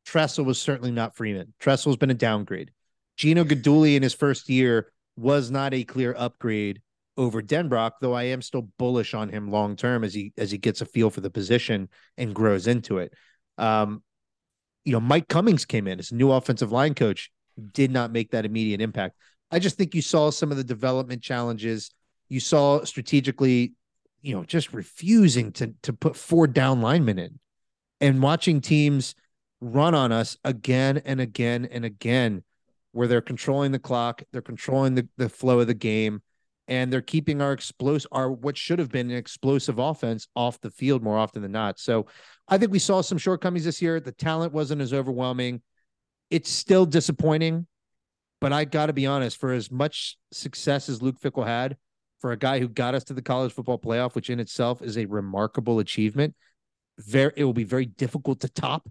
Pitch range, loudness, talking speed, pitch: 115-145 Hz, -25 LUFS, 190 wpm, 130 Hz